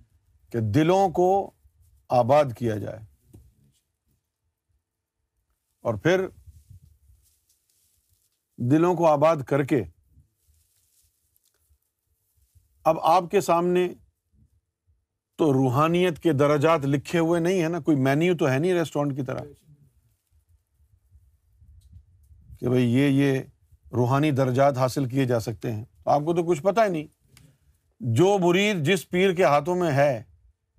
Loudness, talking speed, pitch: -23 LUFS, 115 wpm, 120 Hz